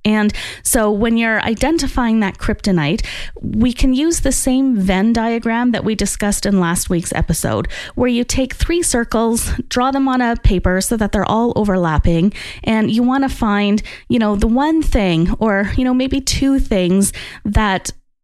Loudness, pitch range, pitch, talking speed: -16 LUFS, 200-255 Hz, 225 Hz, 175 wpm